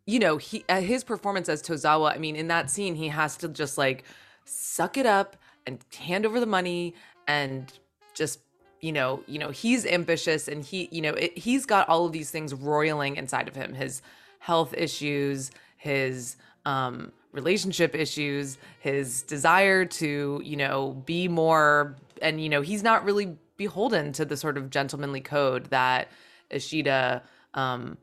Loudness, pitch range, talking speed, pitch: -27 LUFS, 140-175 Hz, 165 wpm, 155 Hz